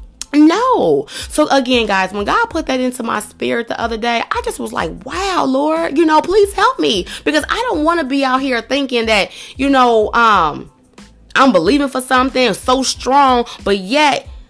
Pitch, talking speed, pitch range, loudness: 265 Hz, 190 wpm, 240-320 Hz, -14 LUFS